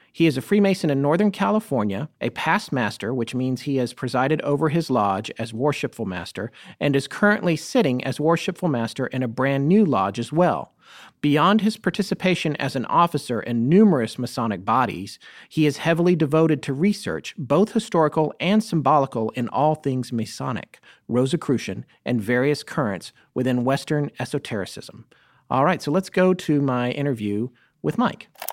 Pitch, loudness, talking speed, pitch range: 145 Hz, -22 LUFS, 160 wpm, 125-170 Hz